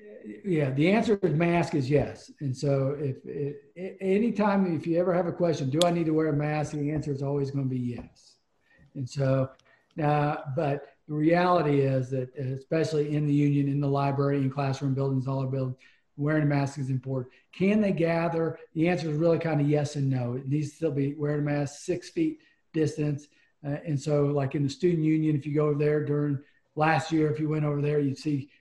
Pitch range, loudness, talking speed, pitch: 140-160 Hz, -27 LUFS, 220 wpm, 150 Hz